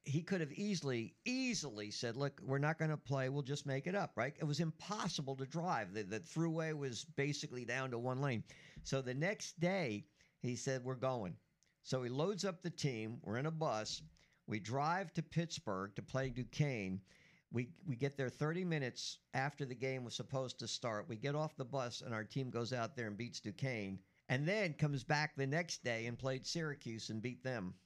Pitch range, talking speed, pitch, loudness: 120-155 Hz, 210 wpm, 135 Hz, -41 LUFS